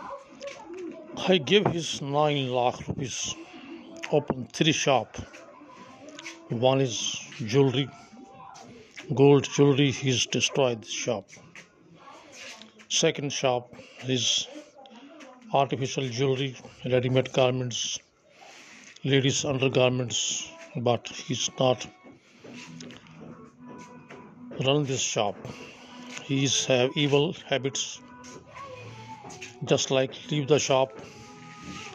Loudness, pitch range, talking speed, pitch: -26 LUFS, 125-160 Hz, 85 wpm, 135 Hz